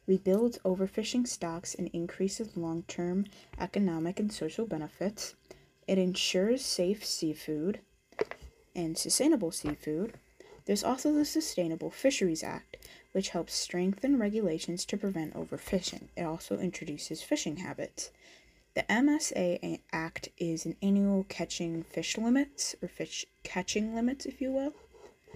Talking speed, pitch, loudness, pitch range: 120 wpm, 190 Hz, -33 LUFS, 170-240 Hz